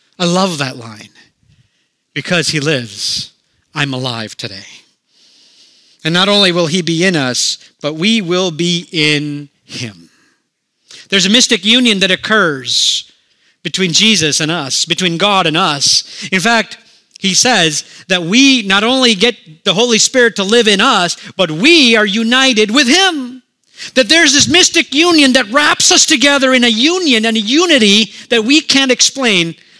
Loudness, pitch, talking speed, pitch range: -10 LUFS, 200 Hz, 160 wpm, 165-250 Hz